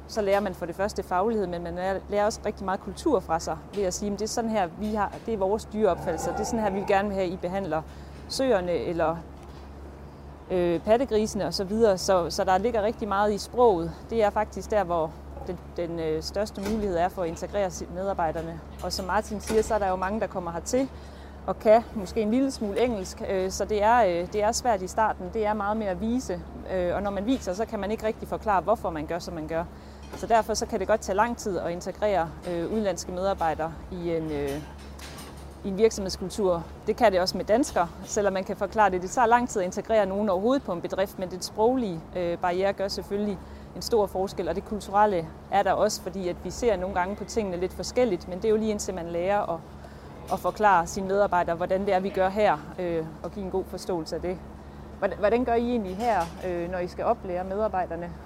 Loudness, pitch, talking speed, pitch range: -27 LUFS, 195 Hz, 235 wpm, 175-210 Hz